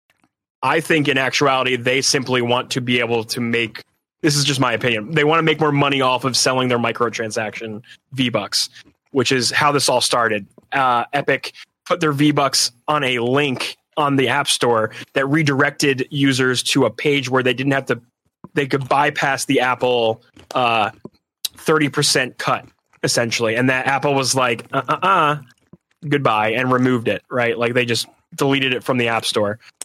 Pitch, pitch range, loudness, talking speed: 130 Hz, 120-145 Hz, -18 LUFS, 180 wpm